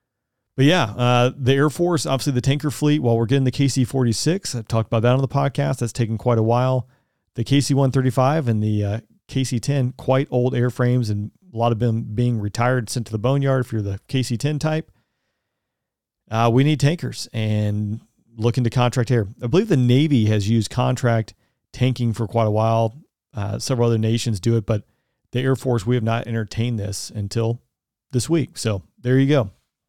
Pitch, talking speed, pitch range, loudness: 125 Hz, 200 wpm, 115-135 Hz, -21 LUFS